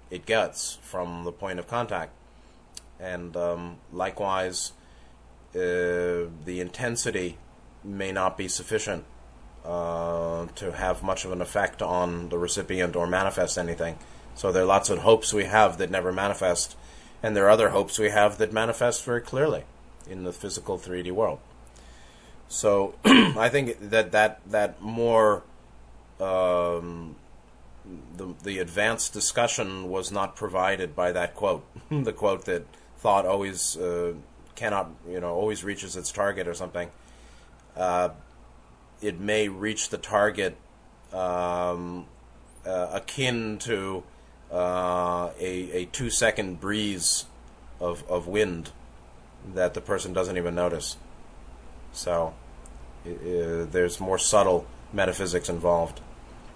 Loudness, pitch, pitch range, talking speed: -26 LUFS, 90 Hz, 85-100 Hz, 130 wpm